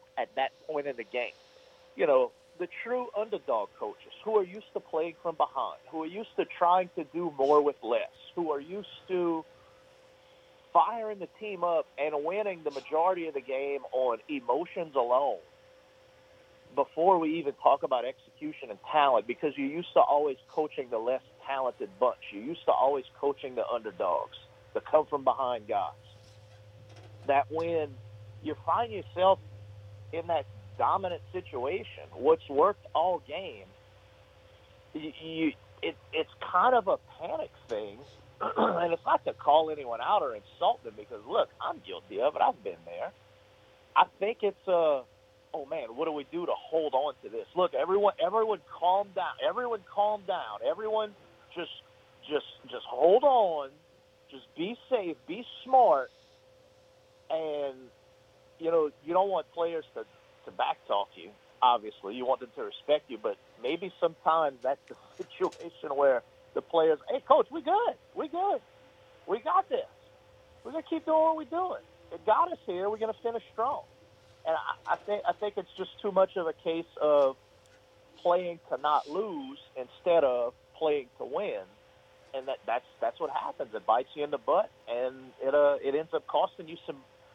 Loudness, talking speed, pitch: -30 LUFS, 170 wpm, 180 Hz